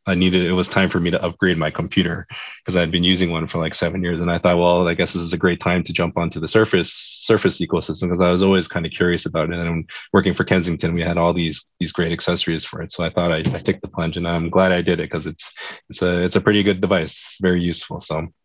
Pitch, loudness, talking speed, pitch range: 90 Hz, -19 LUFS, 285 wpm, 85-90 Hz